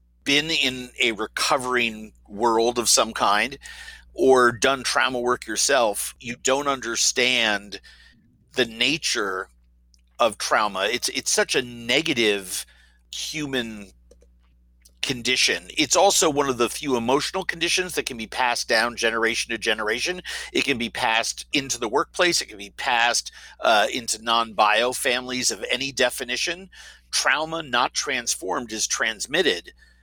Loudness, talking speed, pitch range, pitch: -22 LUFS, 135 wpm, 105-135 Hz, 120 Hz